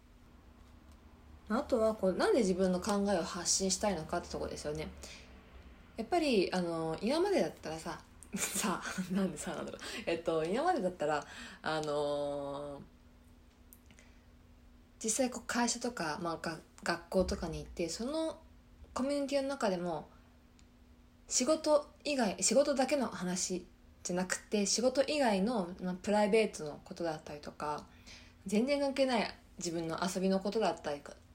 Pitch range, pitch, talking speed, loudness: 140-220 Hz, 180 Hz, 295 characters per minute, -34 LUFS